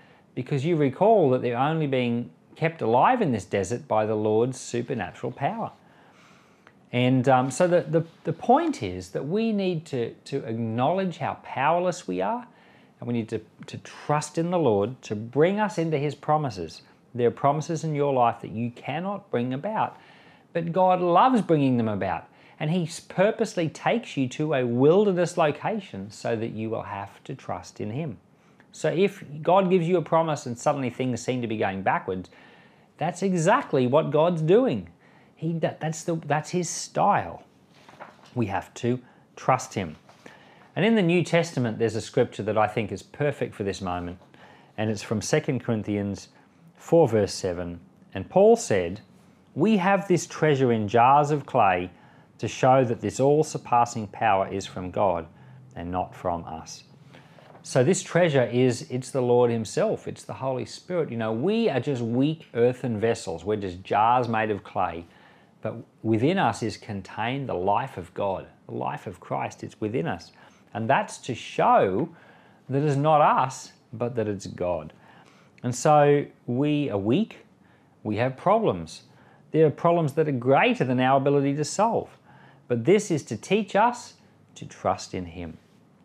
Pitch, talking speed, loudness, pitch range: 130 Hz, 175 wpm, -25 LUFS, 115-160 Hz